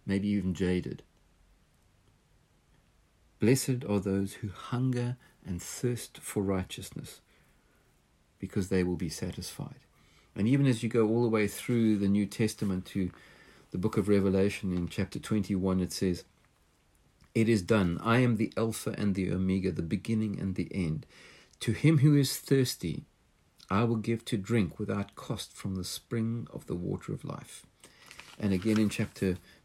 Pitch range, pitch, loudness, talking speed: 95-115 Hz, 100 Hz, -31 LUFS, 160 wpm